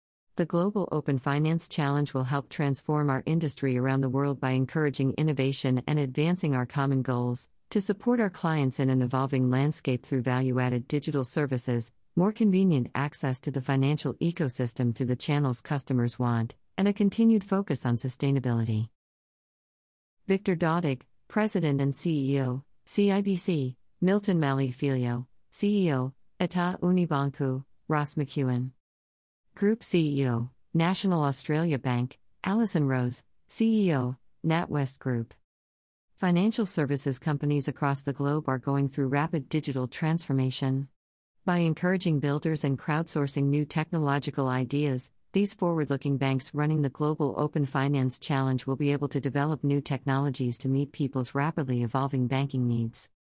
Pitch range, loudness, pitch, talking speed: 130-160 Hz, -28 LUFS, 140 Hz, 135 wpm